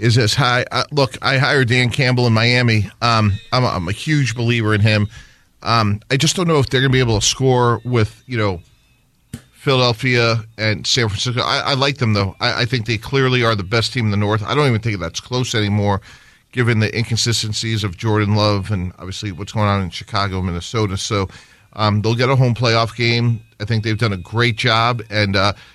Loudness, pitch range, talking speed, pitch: -17 LUFS, 105-125 Hz, 225 wpm, 115 Hz